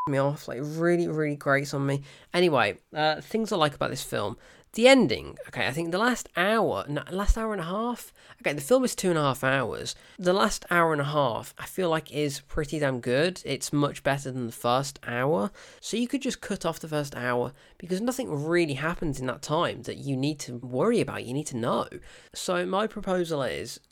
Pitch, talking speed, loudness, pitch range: 155 Hz, 220 wpm, -27 LUFS, 140-185 Hz